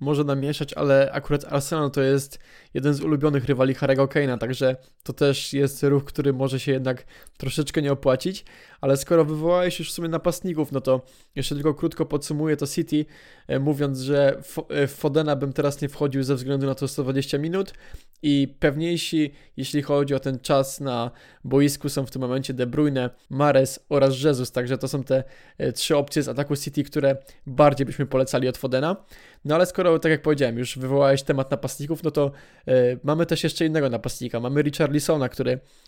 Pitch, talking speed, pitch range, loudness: 140 Hz, 180 wpm, 135-150 Hz, -23 LUFS